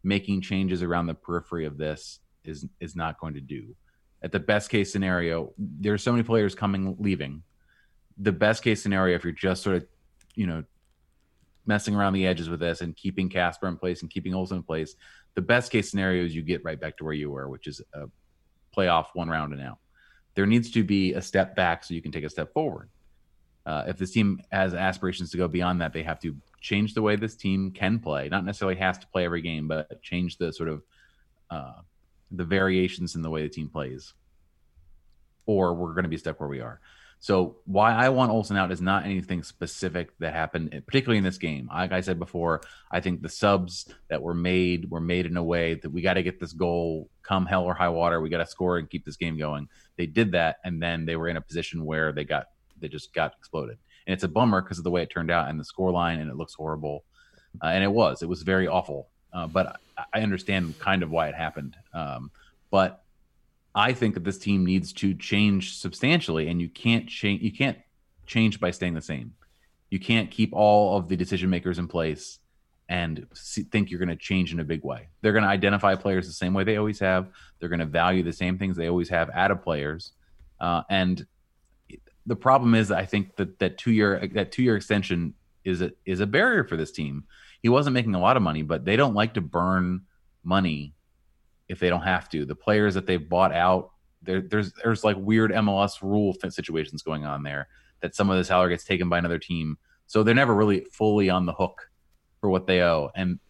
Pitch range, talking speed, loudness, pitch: 80-100 Hz, 225 wpm, -26 LUFS, 90 Hz